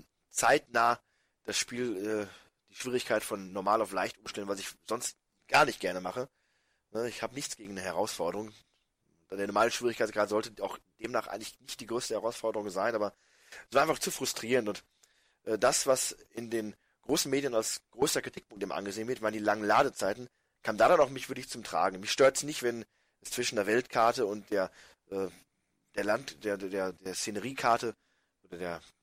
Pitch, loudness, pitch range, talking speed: 110 Hz, -32 LUFS, 100-125 Hz, 190 wpm